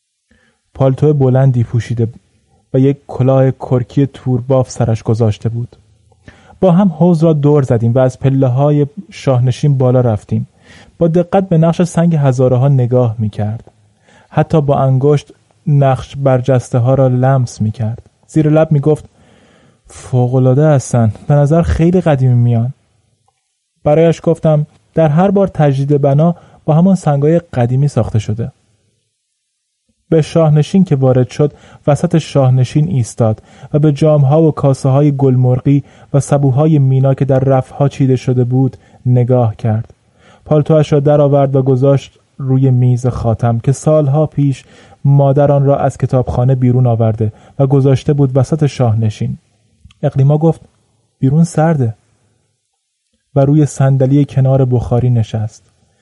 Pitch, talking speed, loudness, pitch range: 135 Hz, 135 wpm, -12 LUFS, 120-150 Hz